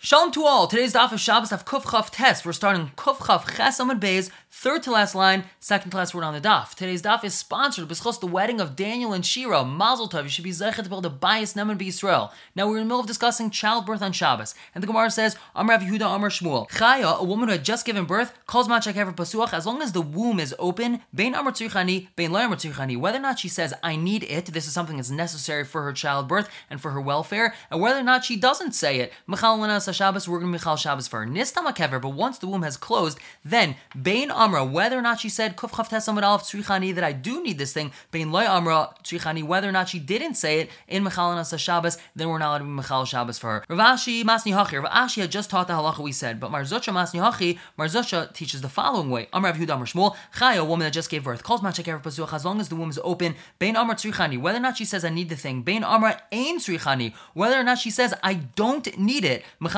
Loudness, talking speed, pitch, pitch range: -23 LUFS, 245 wpm, 190 Hz, 165-225 Hz